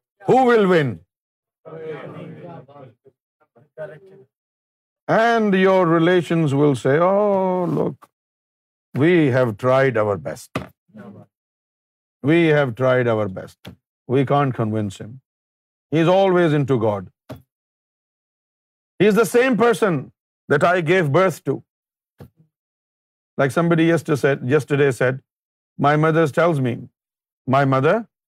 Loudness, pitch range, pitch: -18 LUFS, 130-170 Hz, 145 Hz